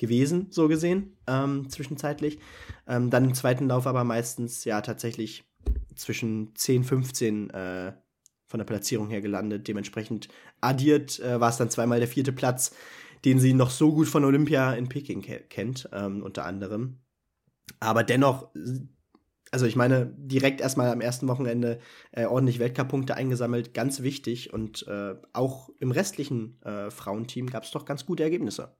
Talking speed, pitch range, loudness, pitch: 160 wpm, 110-135 Hz, -27 LUFS, 125 Hz